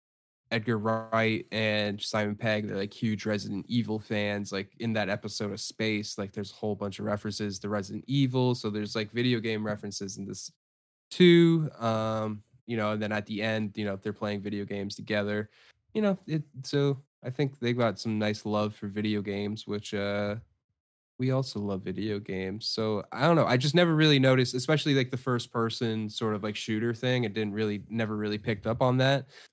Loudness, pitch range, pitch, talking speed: -29 LUFS, 105-120 Hz, 110 Hz, 205 wpm